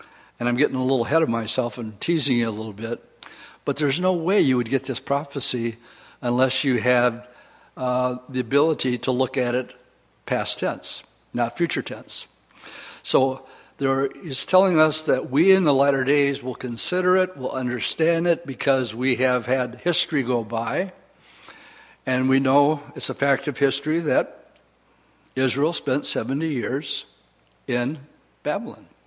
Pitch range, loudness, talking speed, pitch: 125-145 Hz, -22 LUFS, 160 wpm, 130 Hz